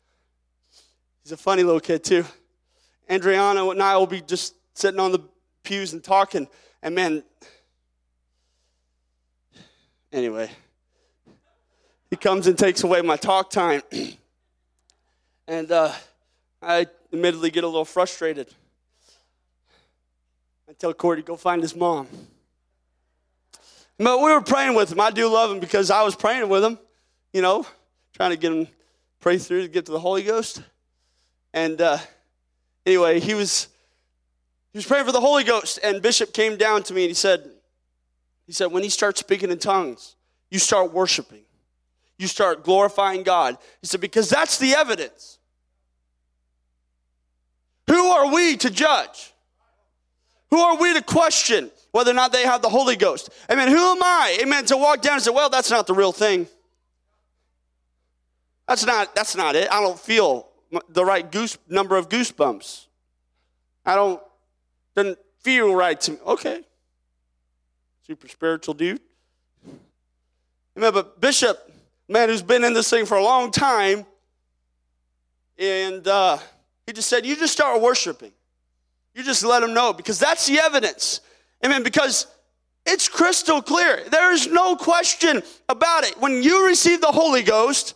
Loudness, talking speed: -20 LUFS, 155 wpm